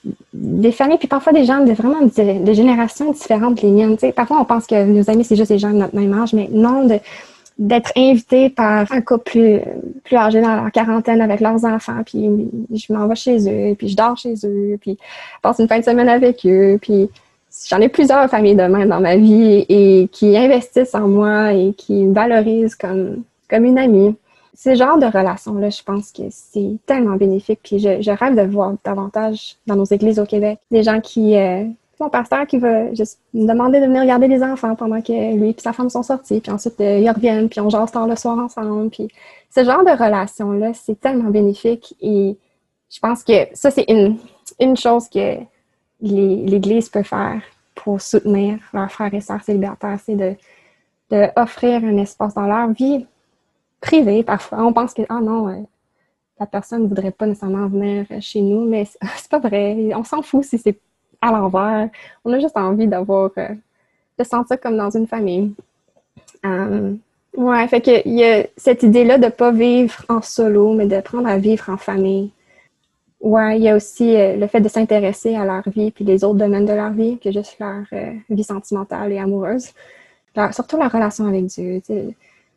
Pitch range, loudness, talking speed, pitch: 205-235 Hz, -15 LUFS, 205 wpm, 220 Hz